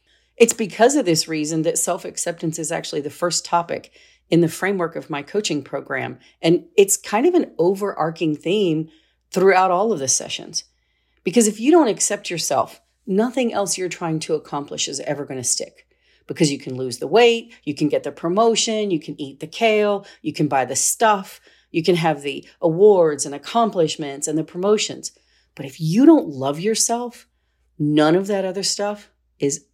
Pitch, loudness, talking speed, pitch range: 175 Hz, -20 LUFS, 185 wpm, 150-220 Hz